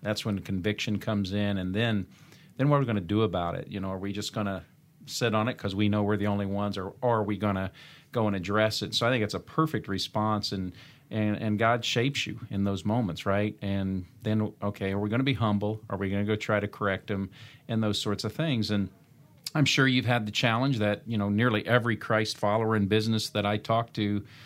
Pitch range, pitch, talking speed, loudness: 100-115 Hz, 105 Hz, 255 wpm, -28 LUFS